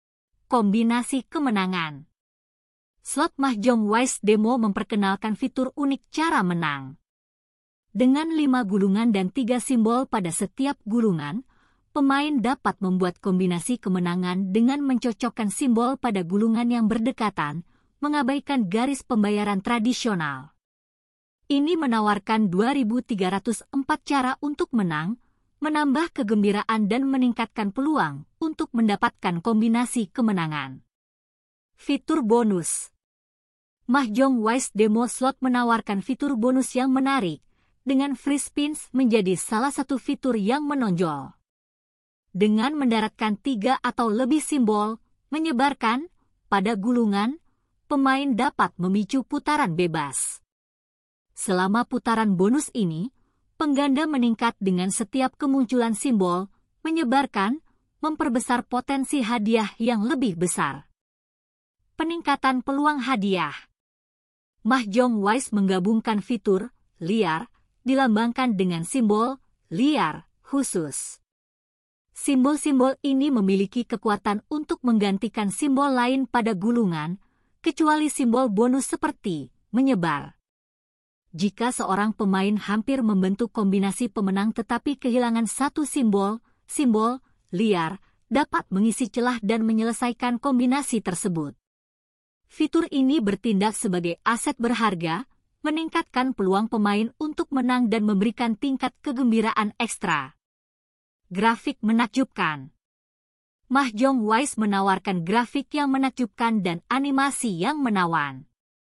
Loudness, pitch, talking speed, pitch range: -24 LUFS, 235 Hz, 100 wpm, 205-270 Hz